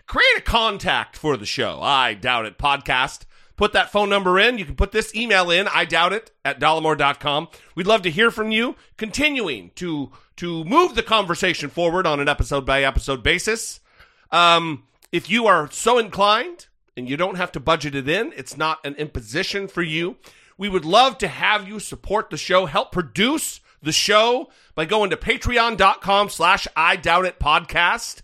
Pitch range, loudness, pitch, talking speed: 155-215 Hz, -19 LUFS, 185 Hz, 185 wpm